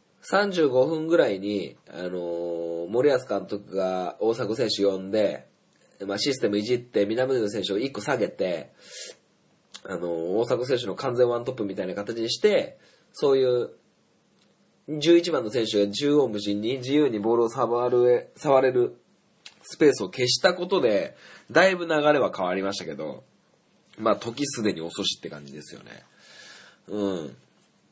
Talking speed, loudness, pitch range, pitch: 280 characters per minute, -25 LUFS, 100-135 Hz, 115 Hz